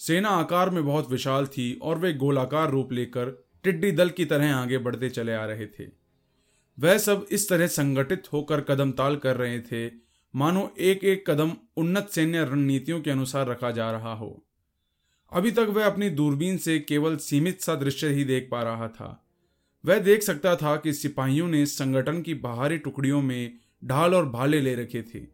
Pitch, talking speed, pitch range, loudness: 145 Hz, 185 wpm, 125-165 Hz, -25 LUFS